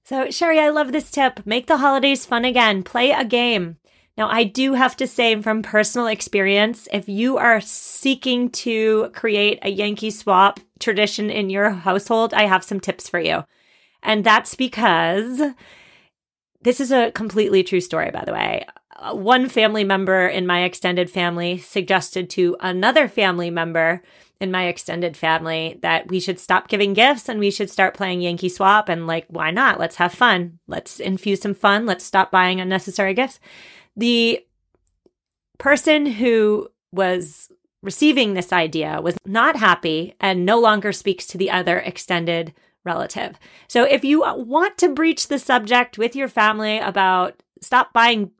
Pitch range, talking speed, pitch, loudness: 185-245 Hz, 165 wpm, 205 Hz, -18 LUFS